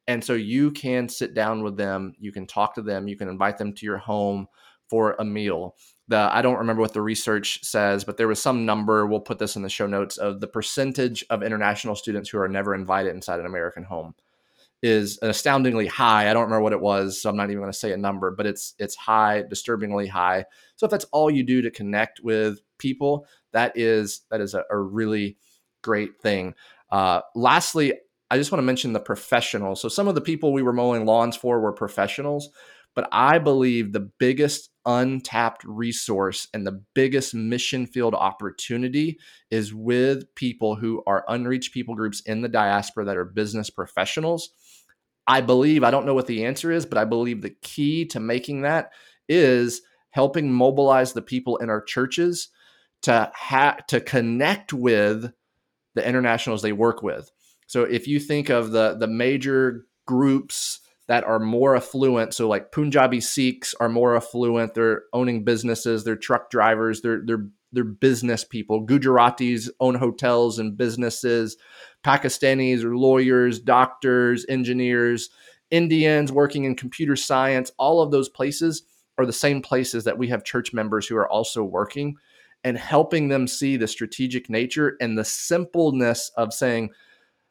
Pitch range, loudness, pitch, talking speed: 110-130 Hz, -23 LUFS, 120 Hz, 180 wpm